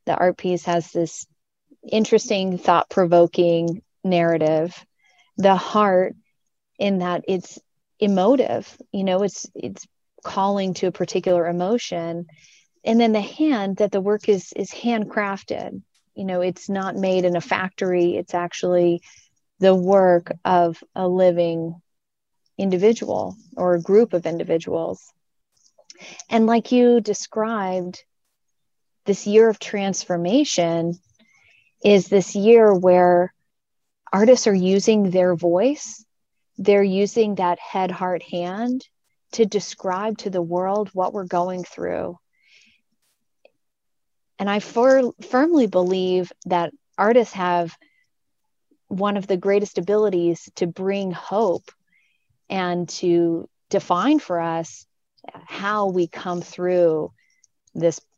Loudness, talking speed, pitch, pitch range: -20 LUFS, 115 wpm, 190 Hz, 175-210 Hz